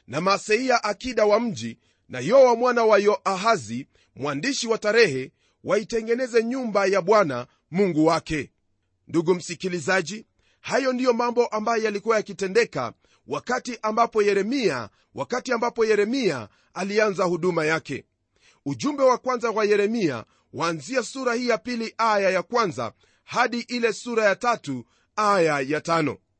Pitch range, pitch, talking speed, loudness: 165-235 Hz, 210 Hz, 140 wpm, -23 LUFS